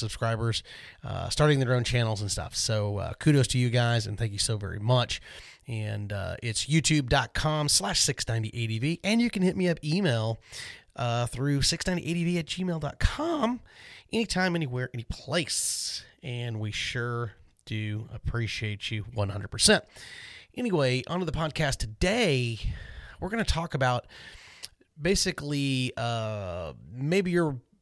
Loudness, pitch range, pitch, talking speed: -28 LUFS, 110-160 Hz, 125 Hz, 135 wpm